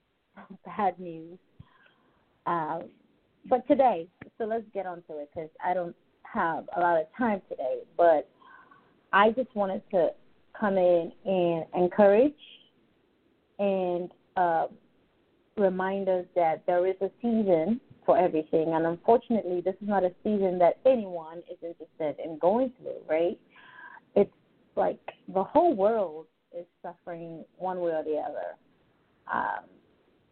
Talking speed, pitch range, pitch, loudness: 140 wpm, 170-220 Hz, 185 Hz, -27 LUFS